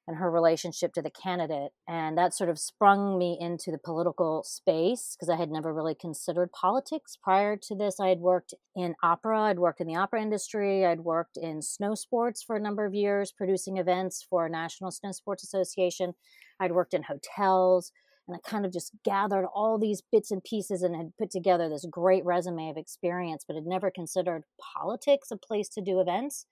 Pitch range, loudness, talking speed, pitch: 170-205 Hz, -29 LUFS, 200 wpm, 185 Hz